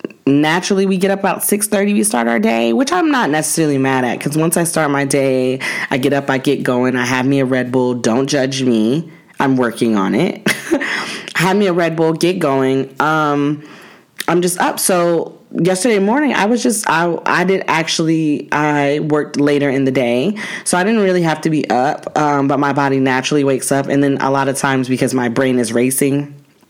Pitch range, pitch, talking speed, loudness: 135-175 Hz, 145 Hz, 215 wpm, -15 LUFS